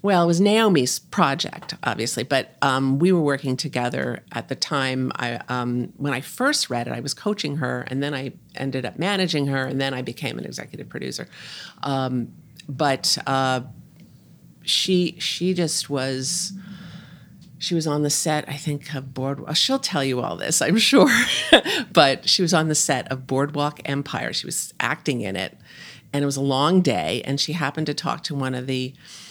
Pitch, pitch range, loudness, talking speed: 145 Hz, 130-170 Hz, -22 LUFS, 190 wpm